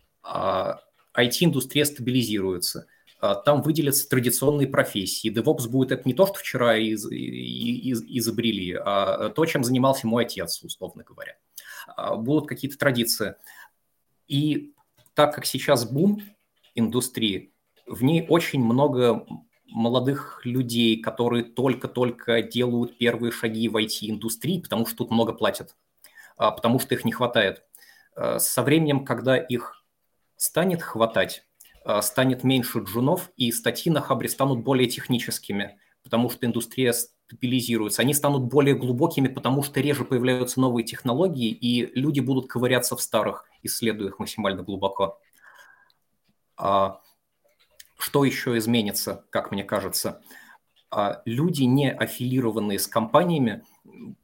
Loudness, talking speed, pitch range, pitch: -24 LUFS, 120 wpm, 115-135 Hz, 125 Hz